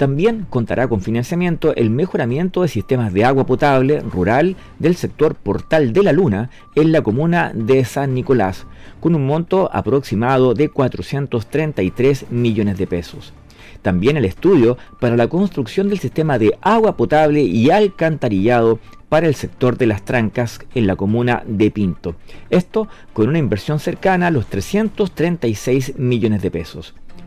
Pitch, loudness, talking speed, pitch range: 130 Hz, -17 LUFS, 150 wpm, 110-160 Hz